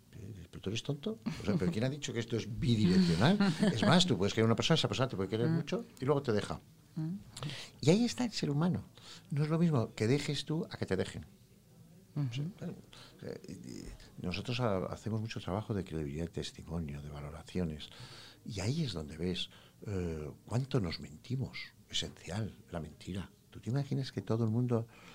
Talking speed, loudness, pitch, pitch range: 180 wpm, -35 LUFS, 115 Hz, 95-150 Hz